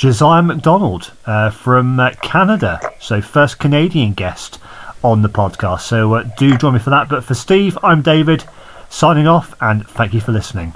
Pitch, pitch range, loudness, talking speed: 130 Hz, 110-155 Hz, -13 LUFS, 180 wpm